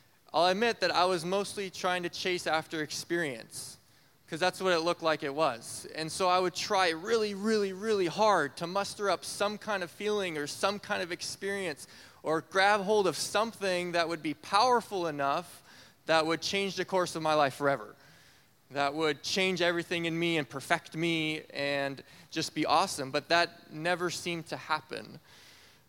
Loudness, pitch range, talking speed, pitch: -30 LUFS, 155-195 Hz, 180 wpm, 170 Hz